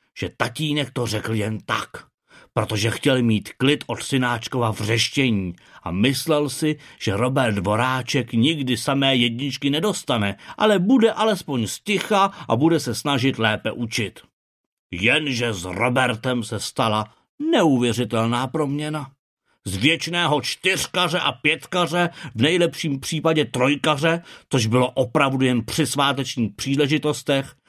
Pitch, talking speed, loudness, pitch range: 135 Hz, 120 wpm, -21 LUFS, 120-155 Hz